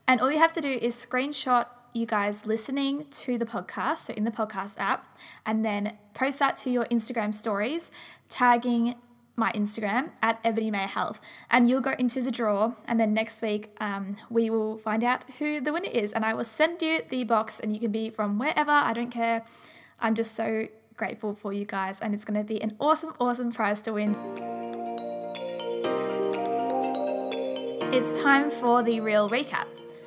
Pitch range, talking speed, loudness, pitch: 210-245 Hz, 185 wpm, -27 LUFS, 225 Hz